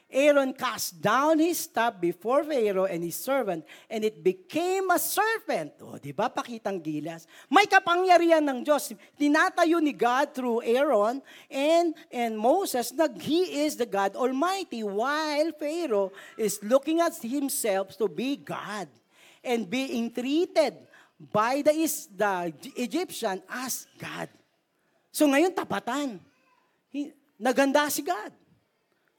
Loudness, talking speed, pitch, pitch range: -26 LUFS, 130 wpm, 275 Hz, 220-320 Hz